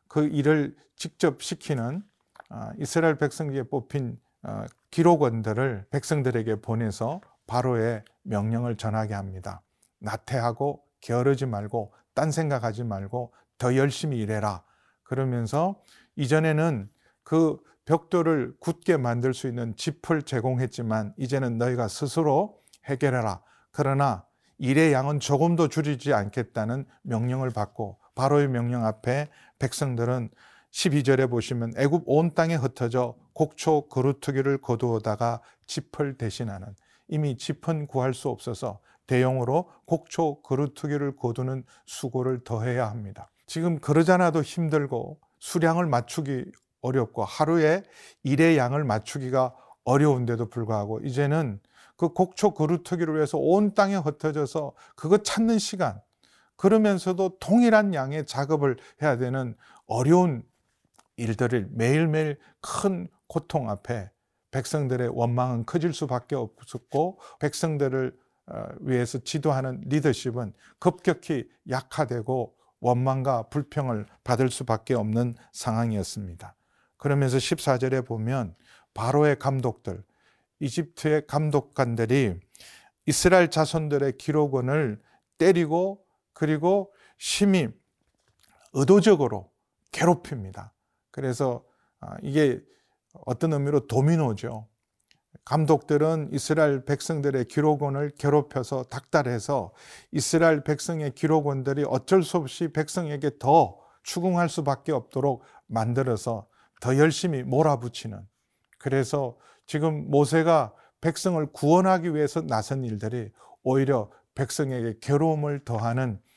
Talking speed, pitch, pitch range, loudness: 275 characters per minute, 135 Hz, 120-155 Hz, -26 LUFS